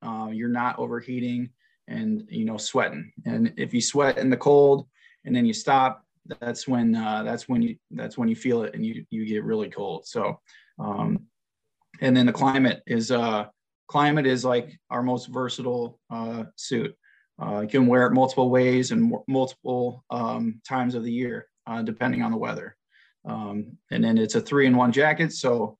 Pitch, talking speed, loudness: 130 Hz, 190 wpm, -24 LUFS